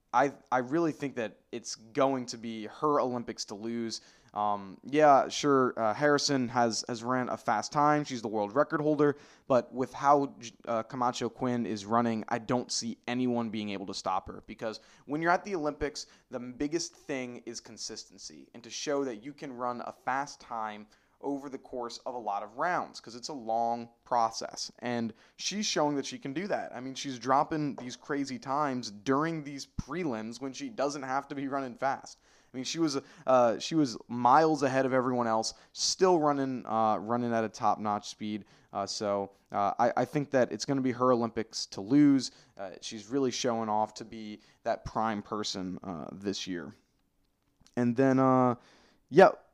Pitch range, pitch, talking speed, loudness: 115-140 Hz, 125 Hz, 195 wpm, -31 LUFS